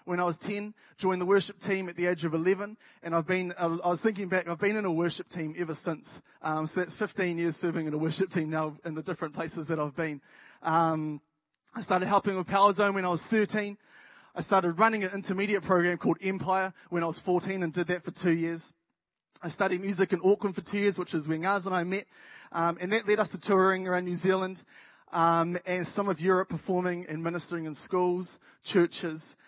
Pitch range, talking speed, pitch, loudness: 165-195 Hz, 225 wpm, 180 Hz, -29 LUFS